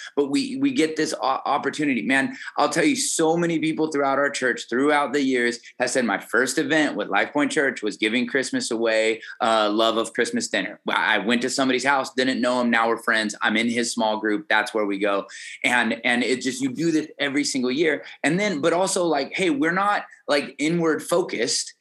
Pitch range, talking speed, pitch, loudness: 115-150 Hz, 215 wpm, 130 Hz, -22 LUFS